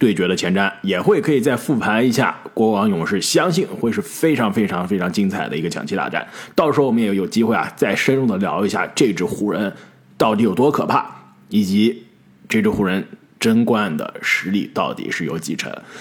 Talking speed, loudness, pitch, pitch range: 305 characters per minute, -19 LUFS, 115 Hz, 105-145 Hz